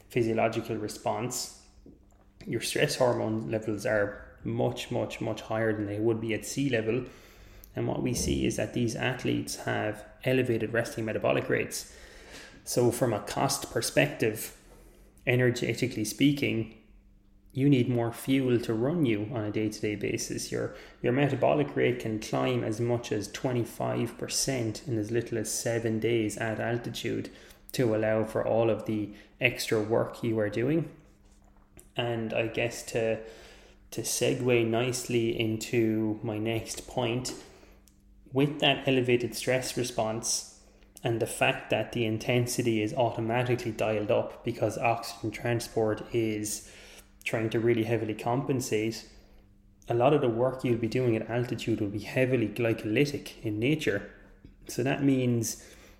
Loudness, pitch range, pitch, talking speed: -29 LUFS, 105-120 Hz, 115 Hz, 140 wpm